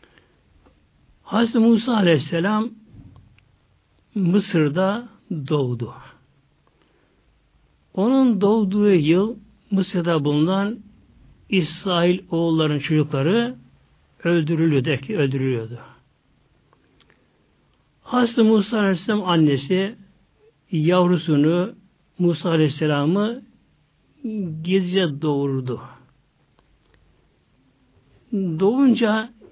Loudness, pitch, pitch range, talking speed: -20 LUFS, 175 Hz, 150-210 Hz, 50 wpm